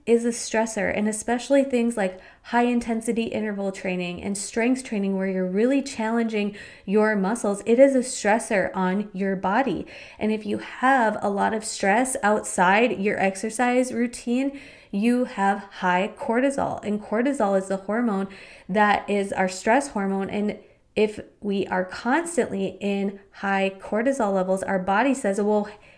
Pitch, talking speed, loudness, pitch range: 210 Hz, 150 wpm, -24 LUFS, 195-240 Hz